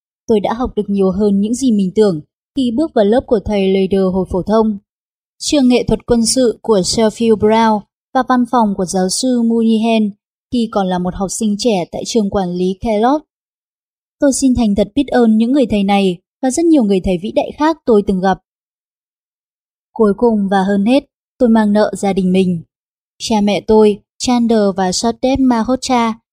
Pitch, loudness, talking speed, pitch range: 220 Hz, -14 LUFS, 195 wpm, 200-245 Hz